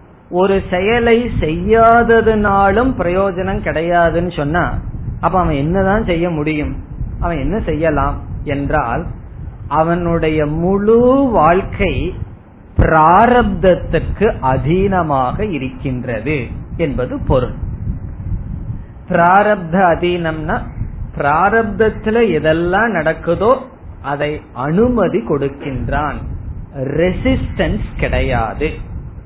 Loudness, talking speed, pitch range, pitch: -15 LUFS, 70 wpm, 135-195 Hz, 165 Hz